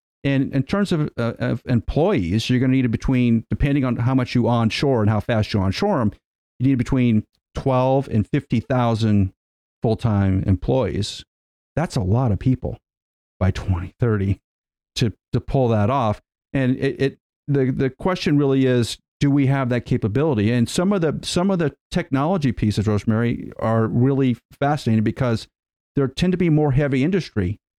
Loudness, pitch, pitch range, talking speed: -21 LUFS, 125 Hz, 110-135 Hz, 175 wpm